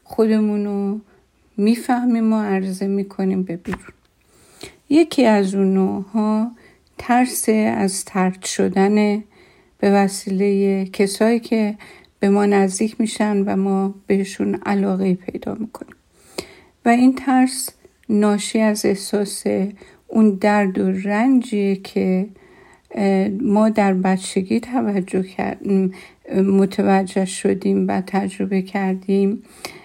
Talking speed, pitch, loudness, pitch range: 100 wpm, 200 Hz, -19 LUFS, 195-220 Hz